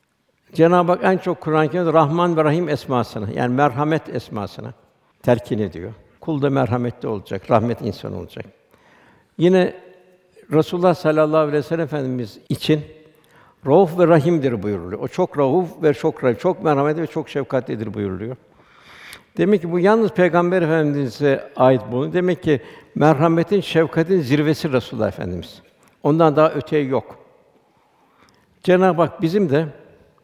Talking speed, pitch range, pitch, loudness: 135 wpm, 130-170 Hz, 155 Hz, -19 LUFS